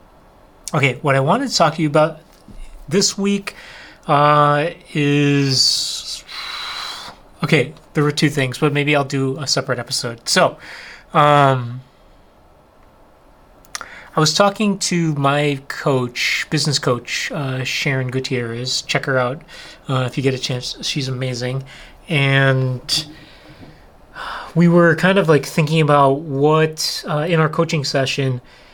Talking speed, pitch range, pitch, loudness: 130 wpm, 130-155 Hz, 140 Hz, -17 LUFS